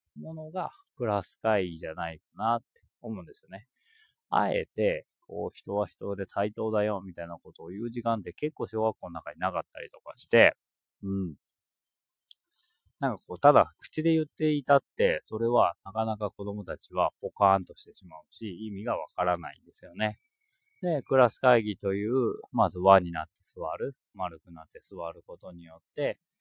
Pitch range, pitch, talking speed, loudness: 95-140 Hz, 105 Hz, 345 characters per minute, -29 LUFS